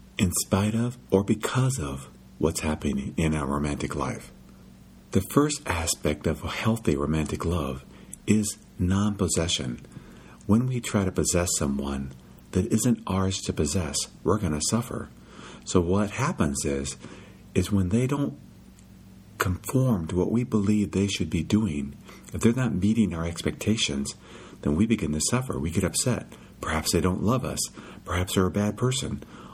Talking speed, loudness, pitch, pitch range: 160 wpm, -26 LUFS, 95 Hz, 75-105 Hz